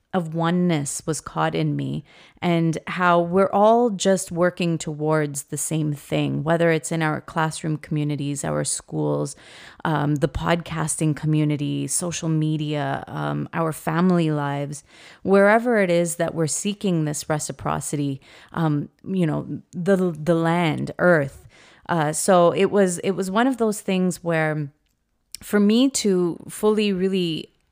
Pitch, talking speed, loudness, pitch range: 165 Hz, 140 wpm, -22 LUFS, 150-180 Hz